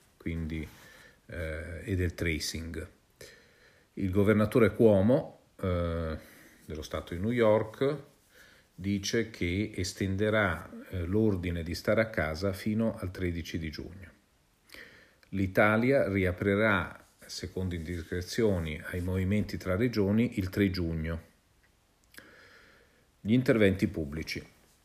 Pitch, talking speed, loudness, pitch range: 95 Hz, 100 wpm, -30 LUFS, 85-105 Hz